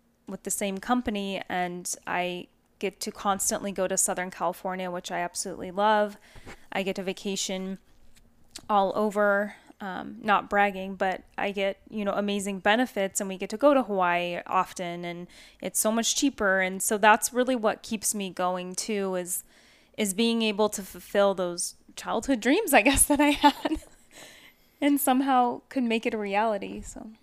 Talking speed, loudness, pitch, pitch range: 170 wpm, -26 LUFS, 200 Hz, 190-225 Hz